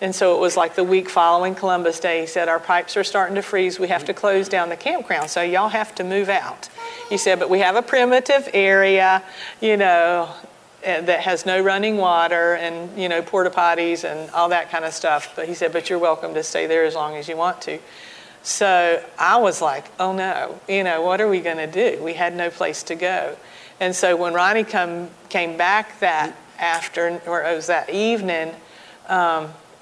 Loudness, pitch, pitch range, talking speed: -20 LUFS, 180 Hz, 170-190 Hz, 215 wpm